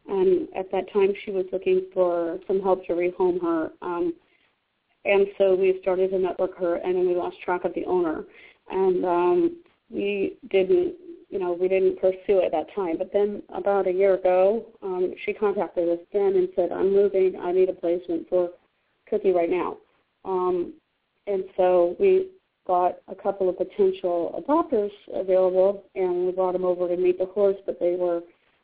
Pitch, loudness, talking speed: 190 Hz, -24 LUFS, 185 wpm